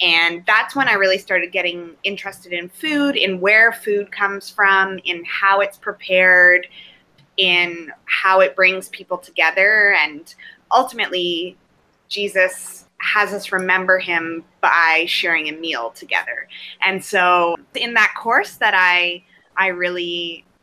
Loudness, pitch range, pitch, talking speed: -16 LUFS, 175-195 Hz, 185 Hz, 135 wpm